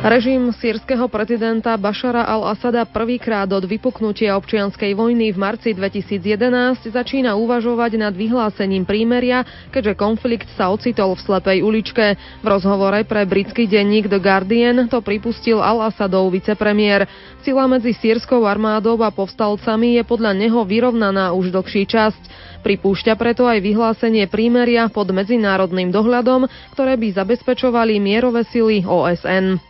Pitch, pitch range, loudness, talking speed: 220 Hz, 200-235 Hz, -17 LUFS, 125 wpm